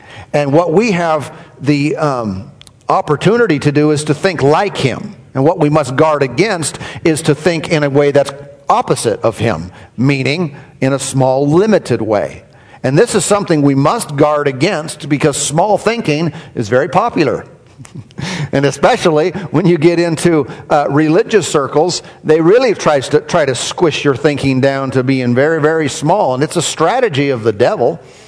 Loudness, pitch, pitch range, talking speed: -13 LUFS, 150 Hz, 140-165 Hz, 170 wpm